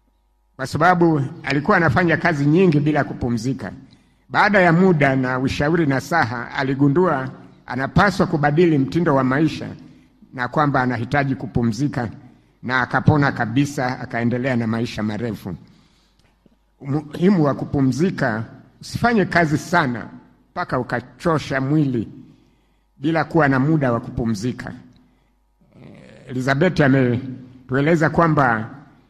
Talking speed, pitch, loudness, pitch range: 105 wpm, 140 Hz, -19 LUFS, 125-160 Hz